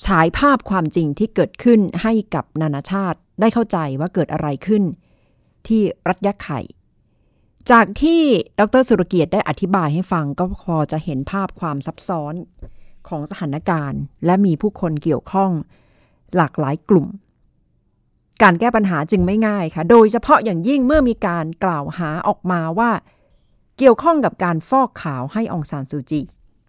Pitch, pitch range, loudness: 185 Hz, 160-215 Hz, -18 LUFS